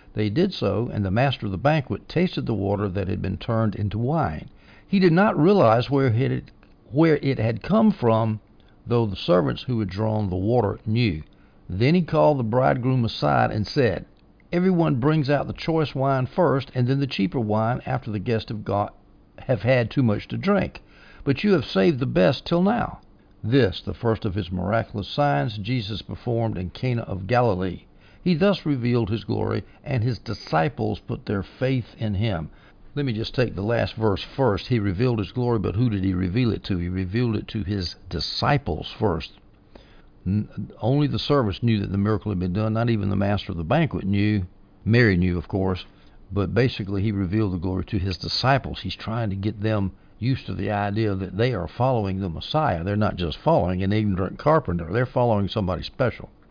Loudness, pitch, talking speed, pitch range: -23 LUFS, 110 Hz, 195 wpm, 100-125 Hz